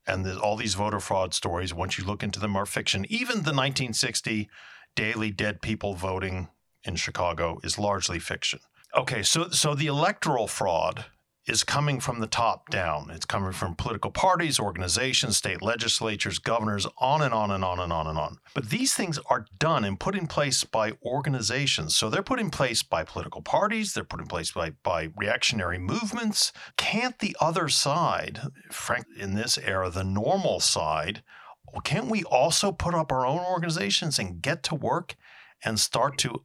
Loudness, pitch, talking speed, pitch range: -27 LUFS, 115 Hz, 180 wpm, 100-155 Hz